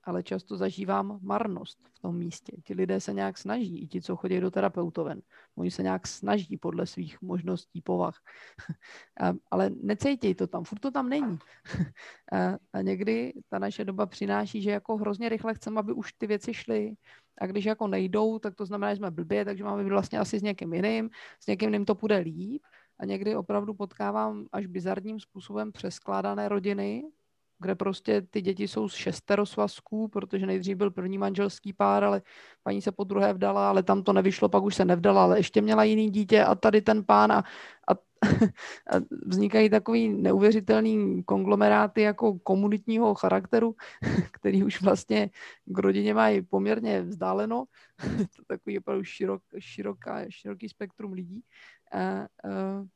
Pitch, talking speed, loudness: 195 Hz, 165 wpm, -28 LUFS